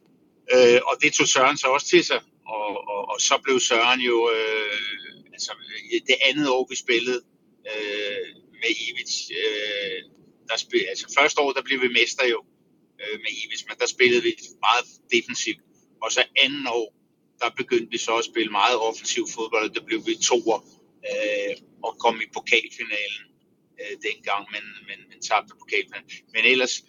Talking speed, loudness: 175 wpm, -22 LUFS